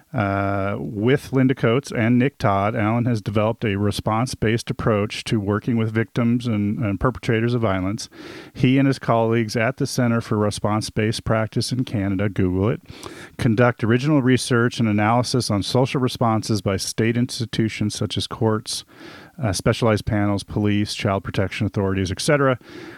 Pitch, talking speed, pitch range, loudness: 115 Hz, 155 wpm, 105-125 Hz, -21 LUFS